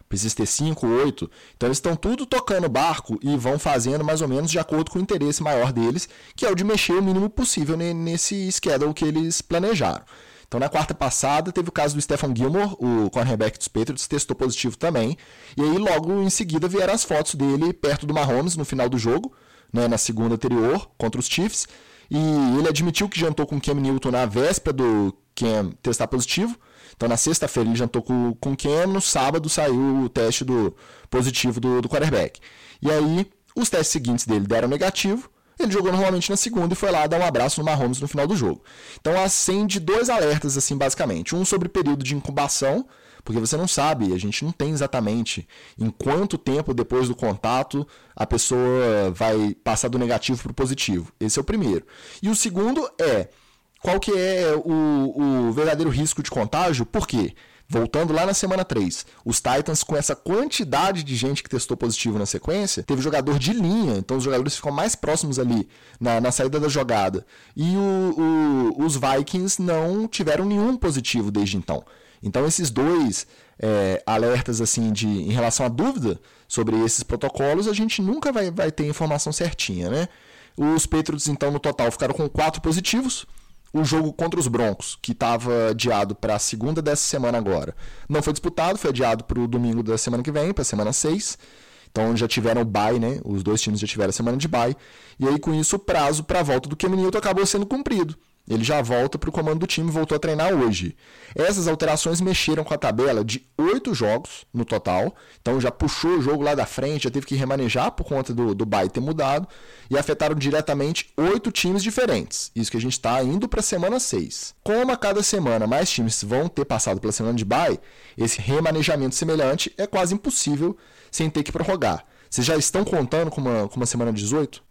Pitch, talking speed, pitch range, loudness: 145 Hz, 200 wpm, 120-170 Hz, -22 LUFS